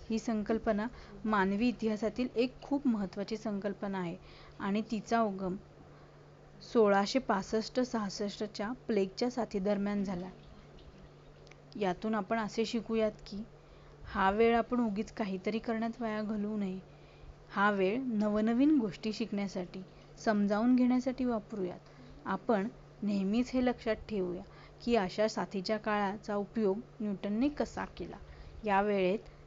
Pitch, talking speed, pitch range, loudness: 215 Hz, 100 wpm, 200-230 Hz, -33 LUFS